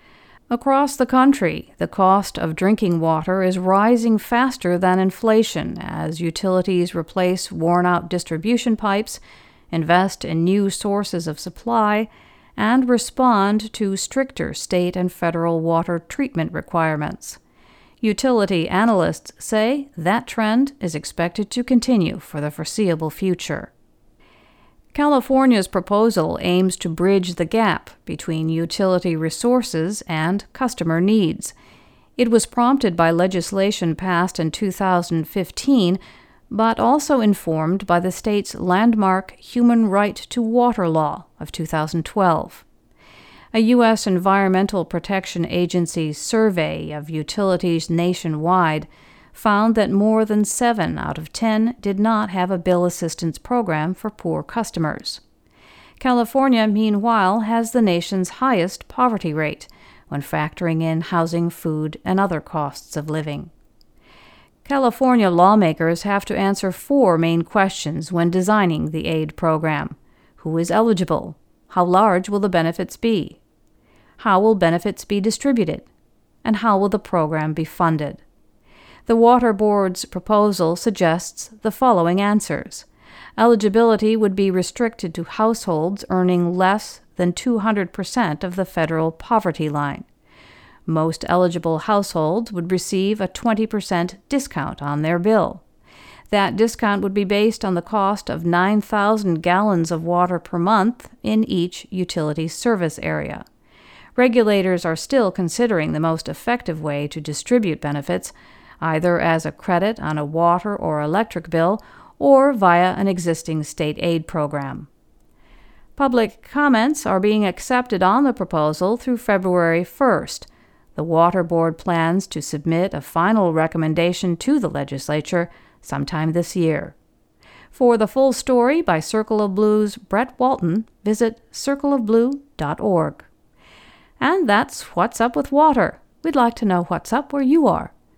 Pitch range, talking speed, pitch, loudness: 170-220 Hz, 130 wpm, 190 Hz, -19 LUFS